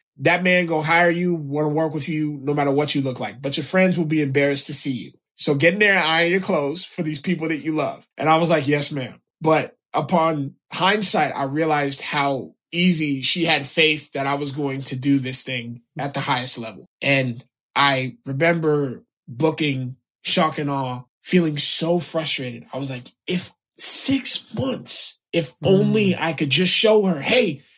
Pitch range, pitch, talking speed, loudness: 140-170 Hz, 155 Hz, 195 wpm, -19 LUFS